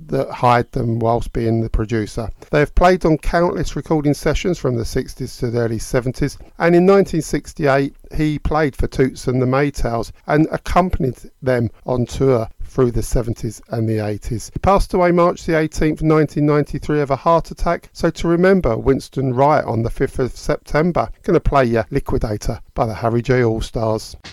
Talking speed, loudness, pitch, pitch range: 180 wpm, -18 LUFS, 135 Hz, 115-155 Hz